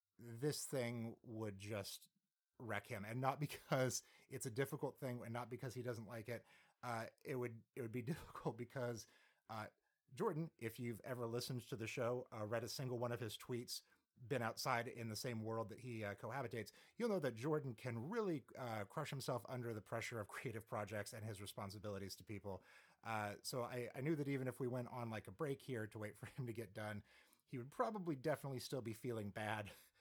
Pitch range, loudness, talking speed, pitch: 110-130 Hz, -47 LUFS, 210 wpm, 120 Hz